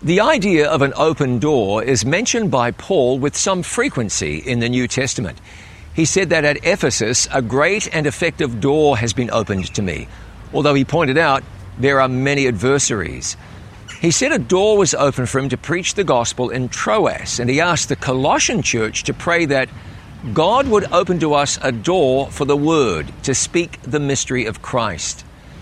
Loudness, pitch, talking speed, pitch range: -17 LUFS, 135 Hz, 185 wpm, 120-160 Hz